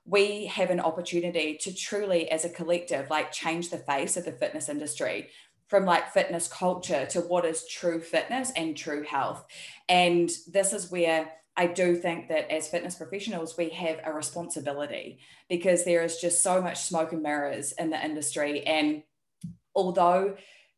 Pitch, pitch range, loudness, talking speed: 170 Hz, 160-180 Hz, -28 LUFS, 170 wpm